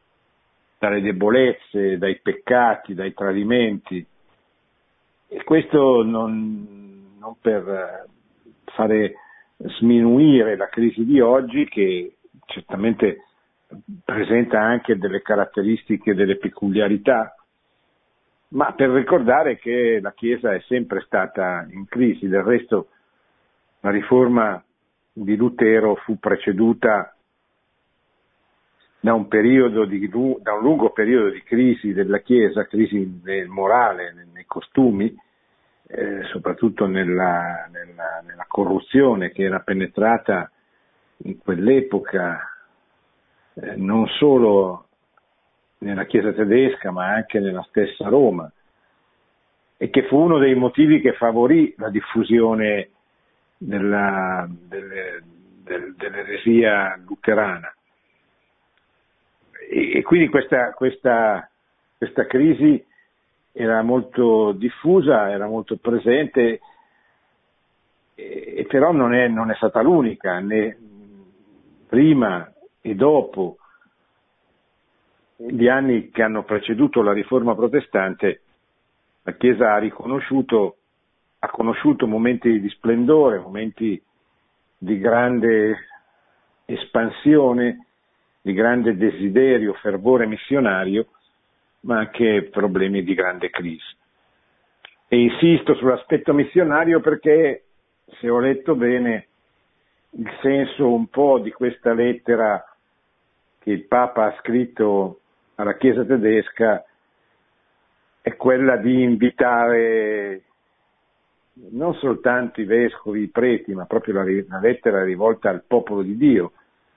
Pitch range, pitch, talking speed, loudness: 100-125 Hz, 115 Hz, 100 wpm, -19 LUFS